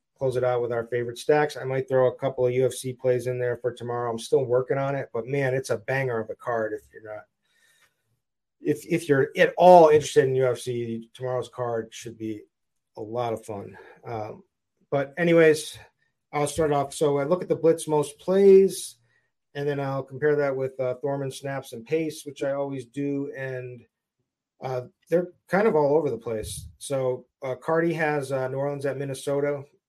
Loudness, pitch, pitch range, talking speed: -25 LUFS, 135 Hz, 125-145 Hz, 195 wpm